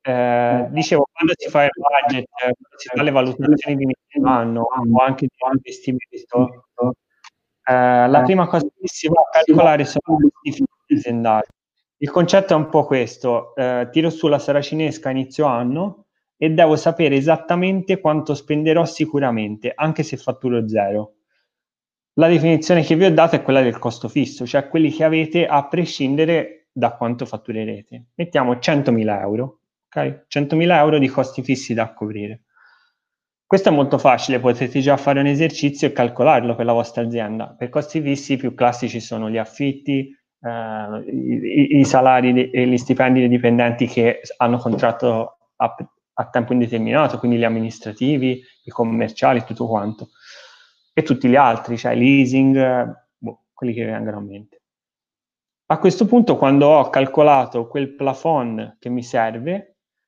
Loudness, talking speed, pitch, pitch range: -18 LUFS, 160 wpm, 135 Hz, 120-155 Hz